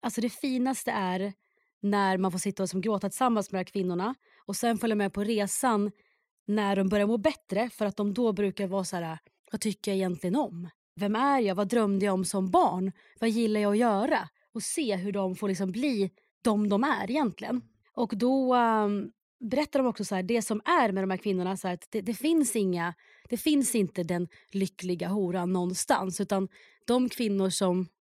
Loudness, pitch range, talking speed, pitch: -29 LUFS, 190-235 Hz, 210 wpm, 205 Hz